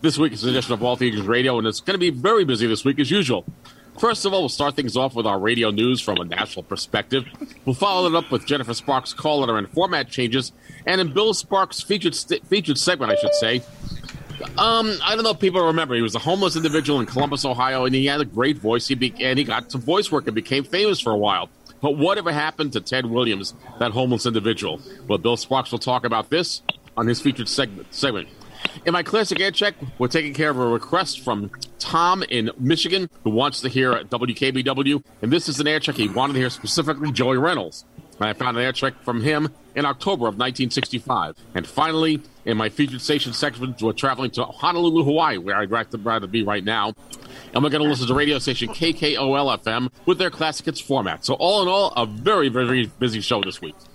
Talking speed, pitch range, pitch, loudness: 225 wpm, 120-155 Hz, 130 Hz, -21 LUFS